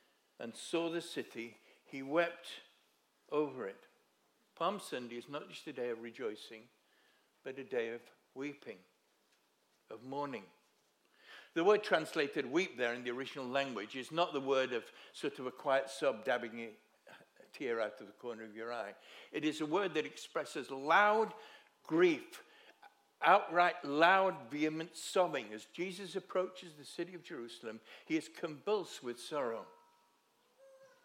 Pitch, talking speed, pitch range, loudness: 145 Hz, 150 wpm, 120-175 Hz, -37 LUFS